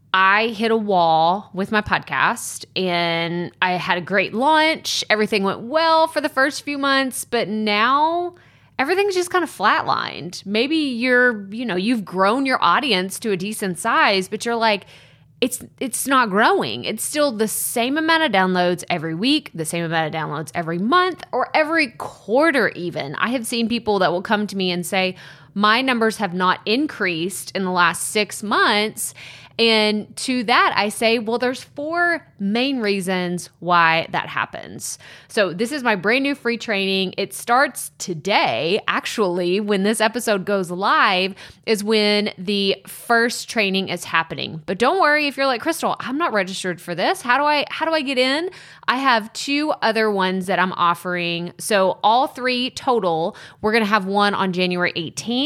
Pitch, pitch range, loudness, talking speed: 210 Hz, 185-255 Hz, -19 LUFS, 180 wpm